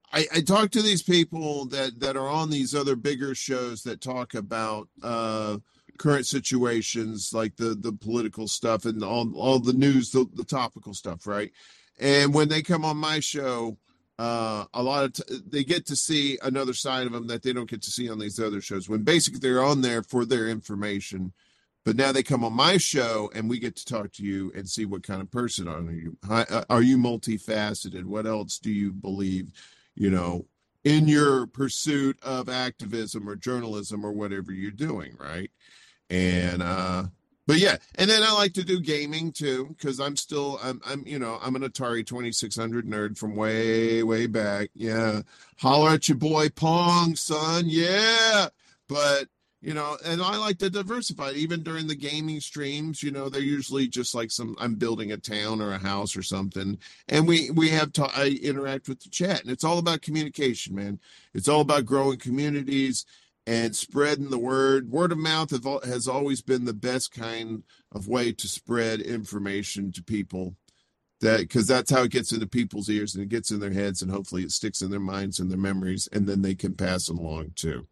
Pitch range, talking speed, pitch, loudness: 105-145 Hz, 195 wpm, 120 Hz, -26 LUFS